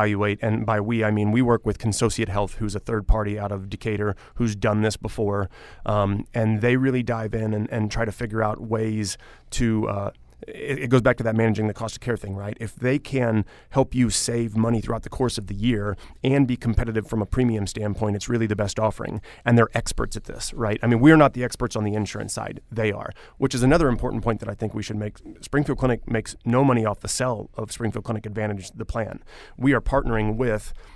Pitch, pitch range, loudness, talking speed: 110 Hz, 105-120 Hz, -24 LUFS, 235 wpm